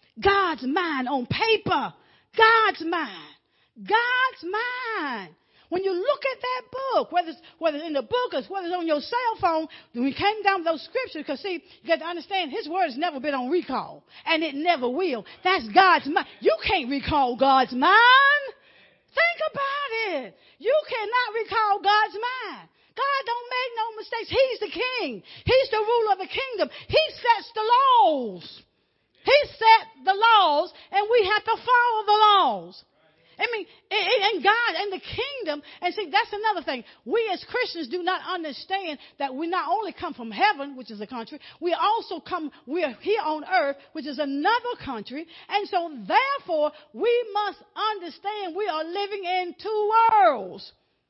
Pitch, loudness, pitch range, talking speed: 370 Hz, -23 LUFS, 310-435 Hz, 175 wpm